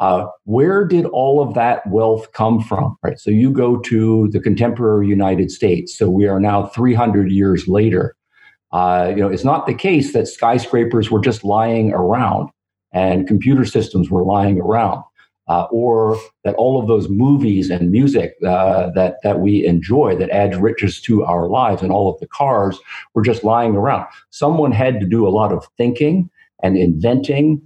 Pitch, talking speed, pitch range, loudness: 110 Hz, 180 wpm, 95-120 Hz, -16 LUFS